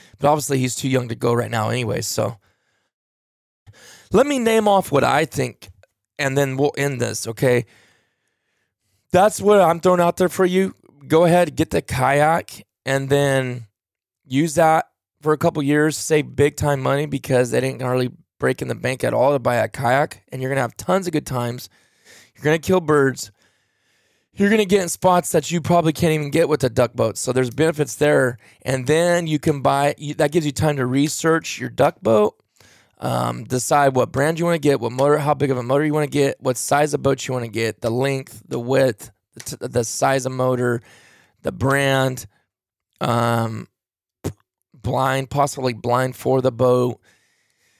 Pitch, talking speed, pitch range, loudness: 135 Hz, 190 wpm, 125-150 Hz, -19 LUFS